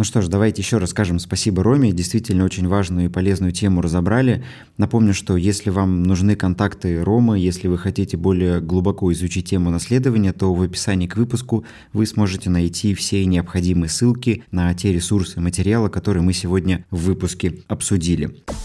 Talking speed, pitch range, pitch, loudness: 170 wpm, 90-105 Hz, 95 Hz, -19 LUFS